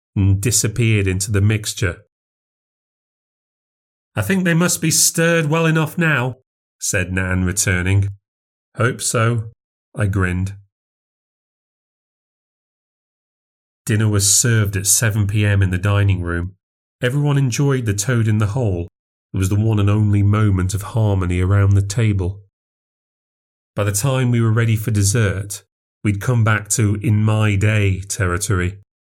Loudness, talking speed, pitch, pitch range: -17 LUFS, 135 wpm, 105 Hz, 95-115 Hz